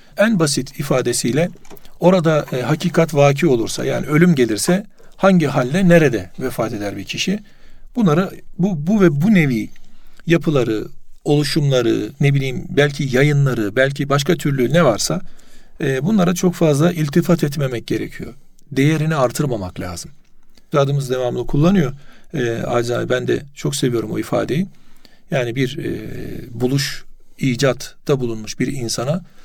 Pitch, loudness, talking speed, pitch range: 145 Hz, -18 LUFS, 130 wpm, 130-175 Hz